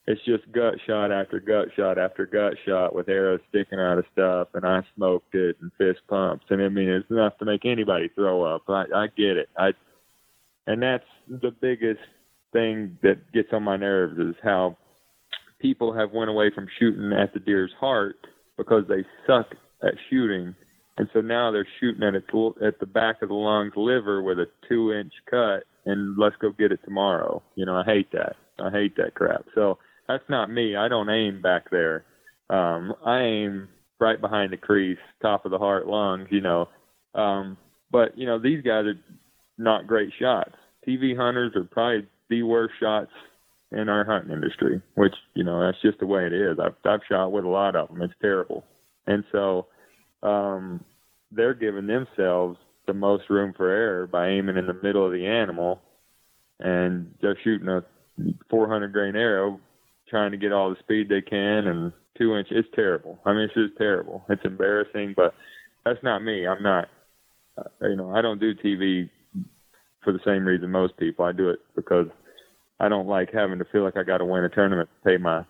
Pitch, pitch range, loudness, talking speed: 100 Hz, 95-110 Hz, -24 LUFS, 195 wpm